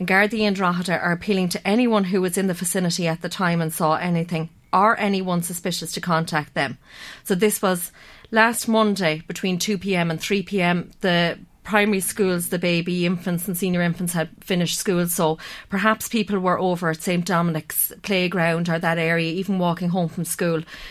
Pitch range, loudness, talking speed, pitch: 170-195 Hz, -22 LUFS, 180 wpm, 180 Hz